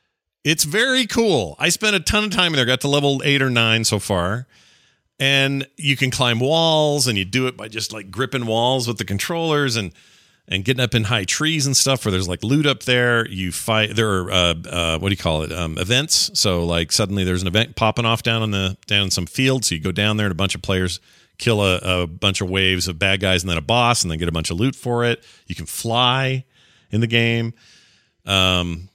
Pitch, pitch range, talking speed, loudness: 115 Hz, 95-130 Hz, 245 wpm, -19 LUFS